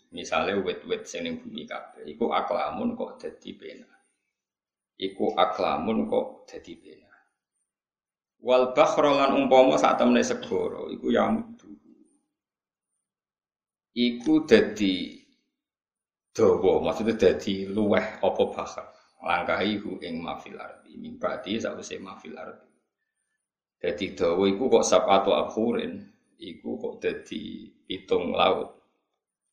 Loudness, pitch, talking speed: -25 LUFS, 270 Hz, 110 wpm